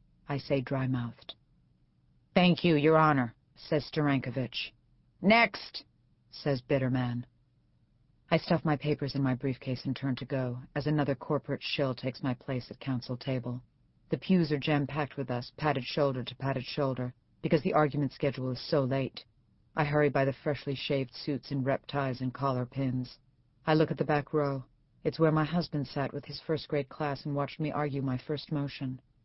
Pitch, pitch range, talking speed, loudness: 140 Hz, 130-150 Hz, 185 wpm, -31 LUFS